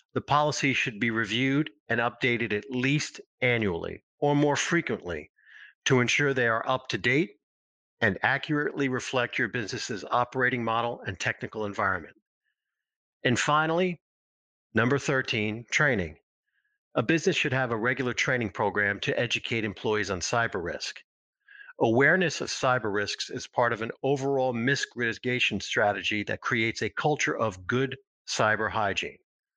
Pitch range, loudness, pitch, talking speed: 110-145 Hz, -27 LUFS, 125 Hz, 140 wpm